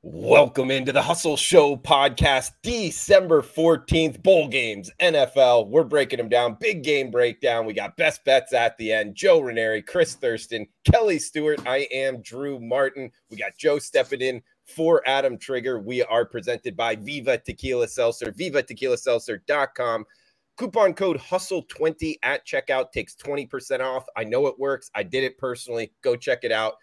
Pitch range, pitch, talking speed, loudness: 130-185 Hz, 140 Hz, 165 wpm, -22 LUFS